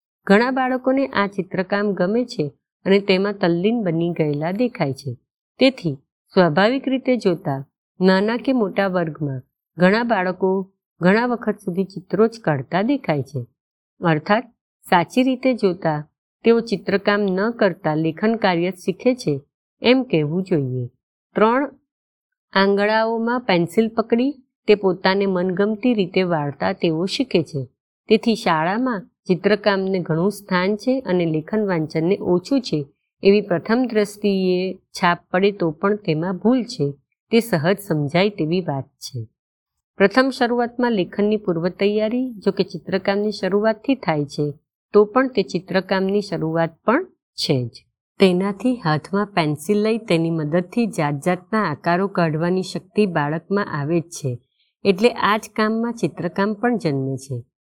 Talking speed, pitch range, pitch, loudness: 135 wpm, 165-220 Hz, 190 Hz, -20 LUFS